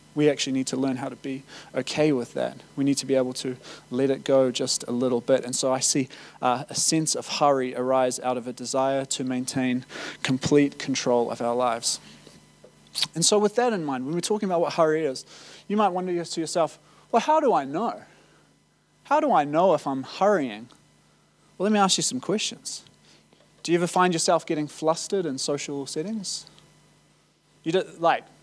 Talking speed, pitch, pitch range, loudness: 200 wpm, 145 Hz, 130-170 Hz, -25 LUFS